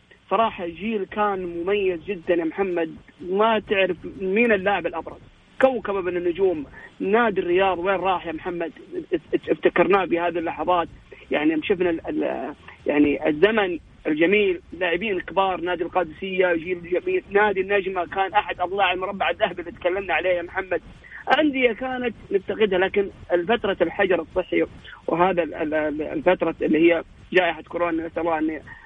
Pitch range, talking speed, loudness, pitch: 175-205 Hz, 130 wpm, -23 LUFS, 185 Hz